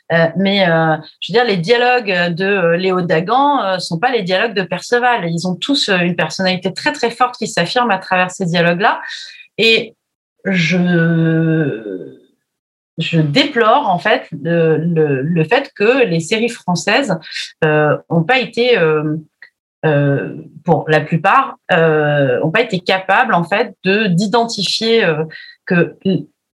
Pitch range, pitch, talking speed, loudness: 165-220 Hz, 180 Hz, 150 wpm, -14 LUFS